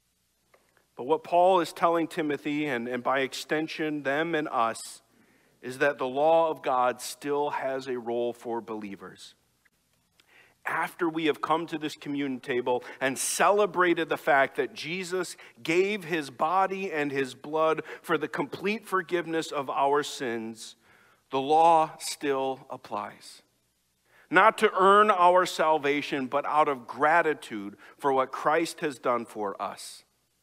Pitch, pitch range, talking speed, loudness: 145 Hz, 125-165 Hz, 140 wpm, -27 LUFS